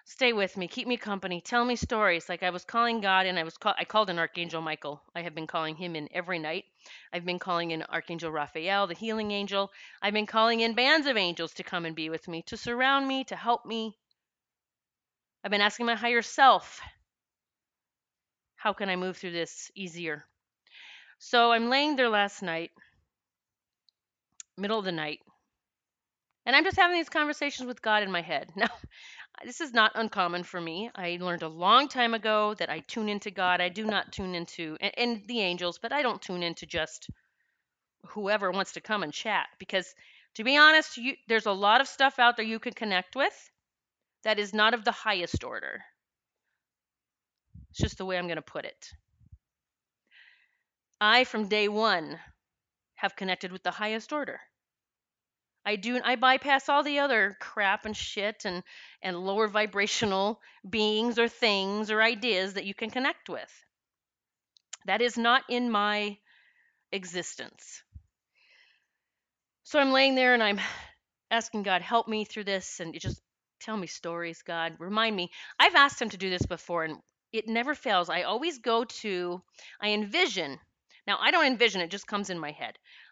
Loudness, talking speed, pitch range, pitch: -28 LUFS, 180 wpm, 180-235 Hz, 210 Hz